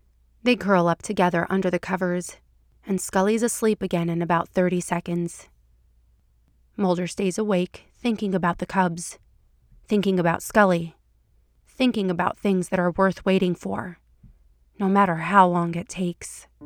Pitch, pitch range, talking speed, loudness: 180 Hz, 170-195 Hz, 140 wpm, -23 LUFS